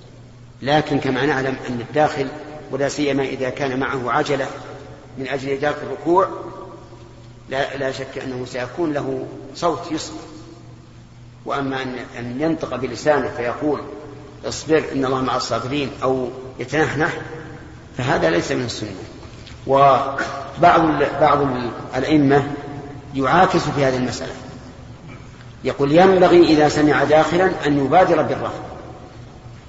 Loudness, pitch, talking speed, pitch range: -19 LUFS, 140 Hz, 110 wpm, 130-150 Hz